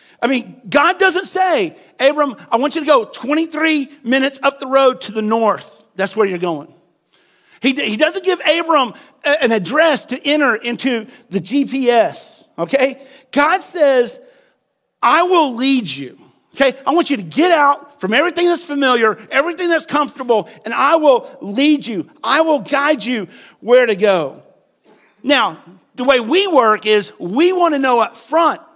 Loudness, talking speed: -15 LUFS, 165 wpm